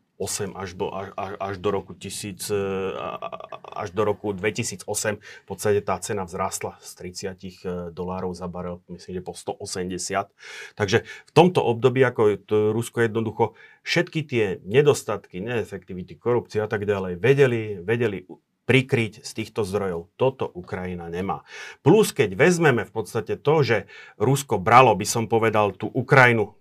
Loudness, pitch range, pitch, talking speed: -23 LUFS, 95-115 Hz, 105 Hz, 145 wpm